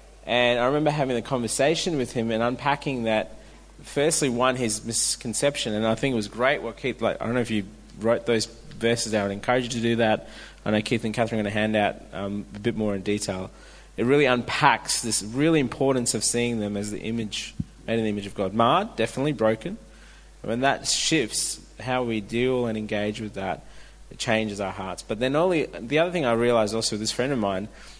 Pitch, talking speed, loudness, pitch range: 115 Hz, 225 wpm, -25 LUFS, 105-125 Hz